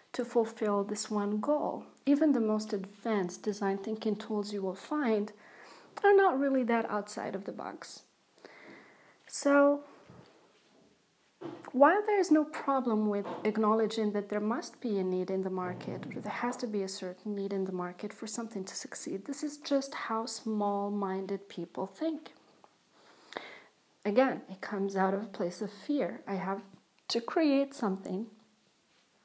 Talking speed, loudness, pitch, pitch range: 160 wpm, -32 LUFS, 215 Hz, 200-255 Hz